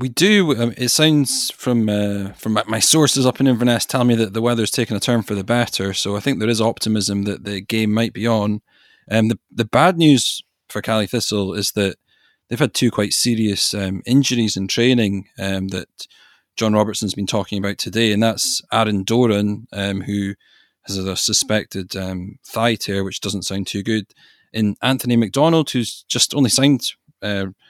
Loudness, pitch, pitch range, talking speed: -18 LUFS, 110 Hz, 100-120 Hz, 190 wpm